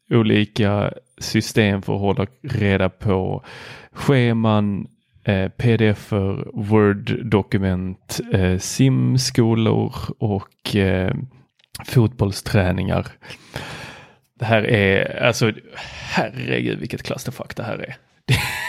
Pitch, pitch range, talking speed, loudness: 105 Hz, 95-120 Hz, 85 wpm, -20 LUFS